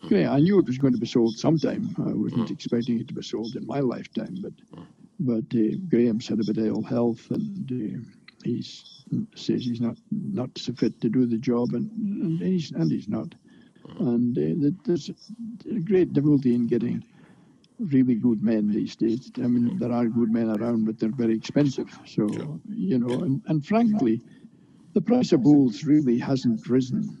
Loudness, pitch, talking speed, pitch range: -25 LUFS, 125 Hz, 185 wpm, 115-170 Hz